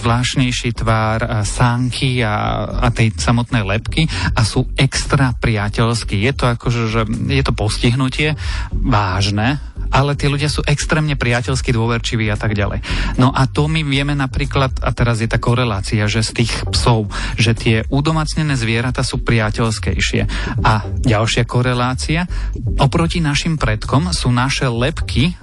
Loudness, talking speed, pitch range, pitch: -17 LUFS, 145 wpm, 110-135 Hz, 120 Hz